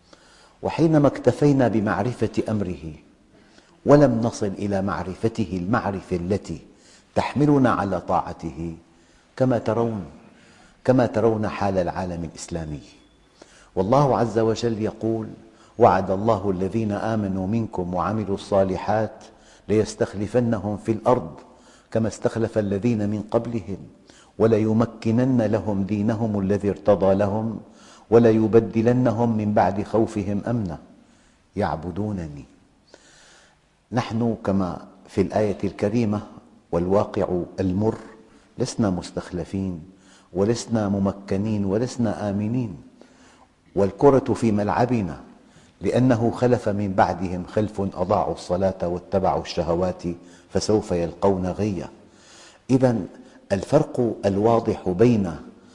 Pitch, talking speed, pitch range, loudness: 105 Hz, 90 wpm, 95-115 Hz, -23 LUFS